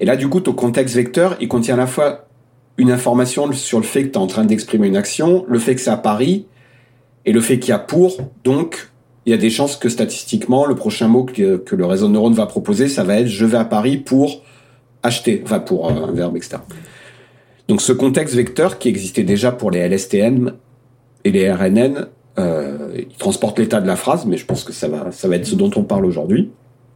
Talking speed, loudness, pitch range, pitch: 235 wpm, -16 LUFS, 120-155 Hz, 125 Hz